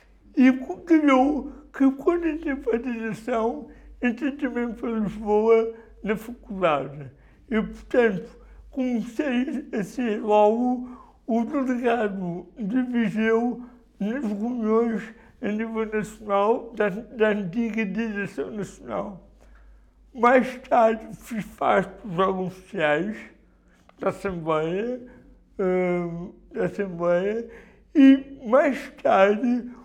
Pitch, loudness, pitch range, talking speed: 225 Hz, -24 LUFS, 200-250 Hz, 95 wpm